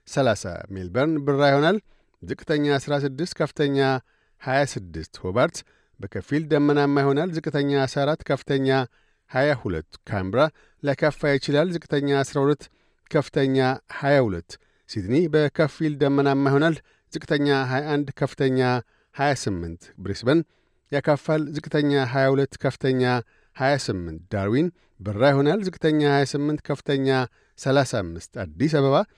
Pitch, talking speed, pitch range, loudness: 140 Hz, 100 wpm, 130-150 Hz, -23 LUFS